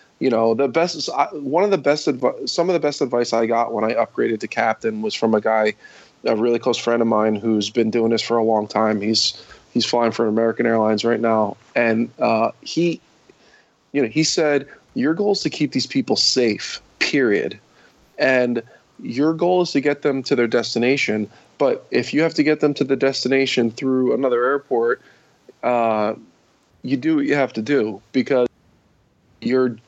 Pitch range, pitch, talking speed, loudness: 115-150 Hz, 120 Hz, 195 wpm, -20 LUFS